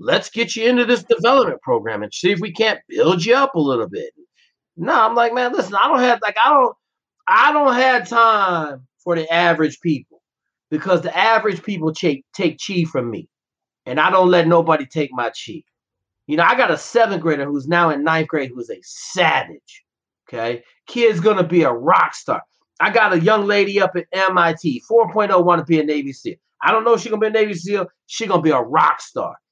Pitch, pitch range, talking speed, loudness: 190 Hz, 160-230 Hz, 220 wpm, -17 LUFS